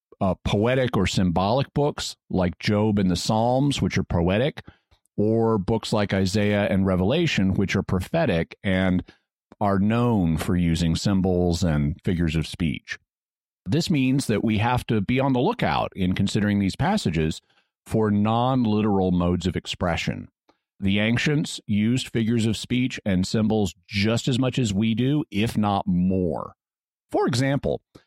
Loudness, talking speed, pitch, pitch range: -23 LUFS, 150 wpm, 105 Hz, 95-115 Hz